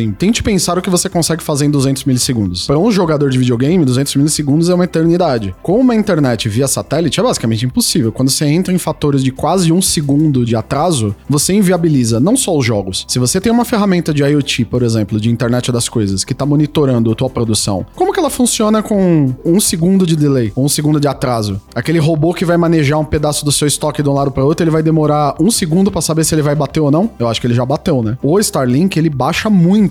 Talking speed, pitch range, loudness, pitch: 235 wpm, 125-175 Hz, -13 LUFS, 150 Hz